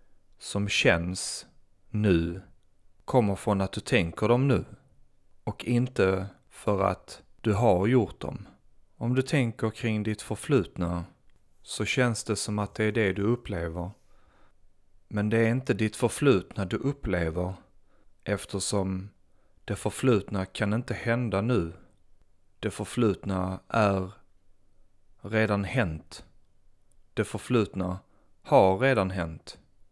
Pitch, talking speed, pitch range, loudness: 100 Hz, 120 wpm, 95-110 Hz, -28 LUFS